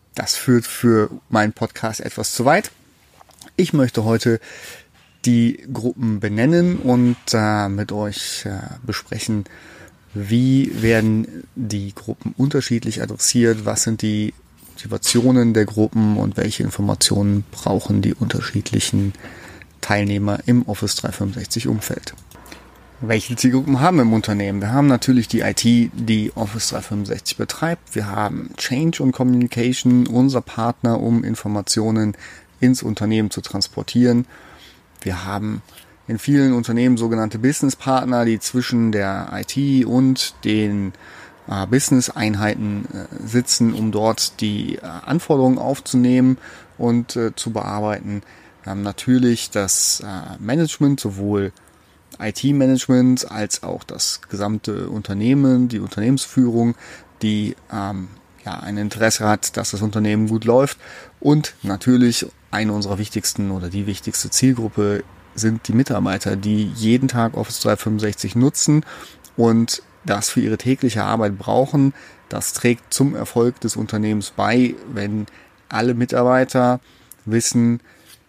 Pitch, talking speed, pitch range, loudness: 115 Hz, 125 wpm, 105-125 Hz, -19 LUFS